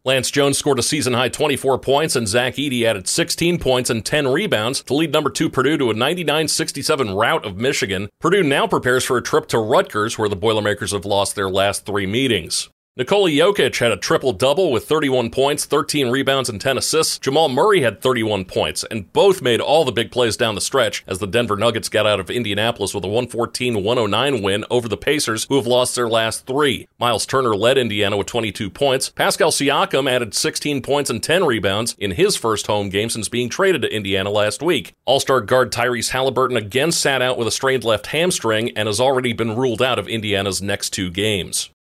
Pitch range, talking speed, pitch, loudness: 105-135 Hz, 205 wpm, 120 Hz, -18 LUFS